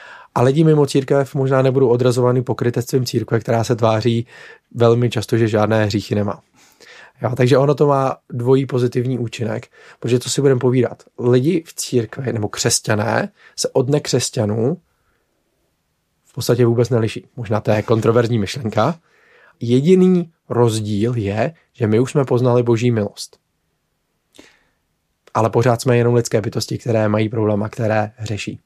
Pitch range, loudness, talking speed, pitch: 110-130 Hz, -17 LUFS, 145 wpm, 120 Hz